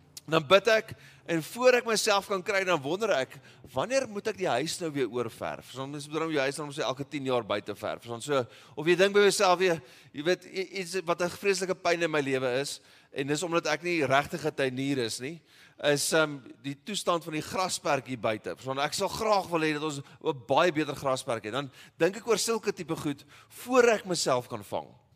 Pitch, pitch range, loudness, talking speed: 155 Hz, 135-185 Hz, -29 LUFS, 230 wpm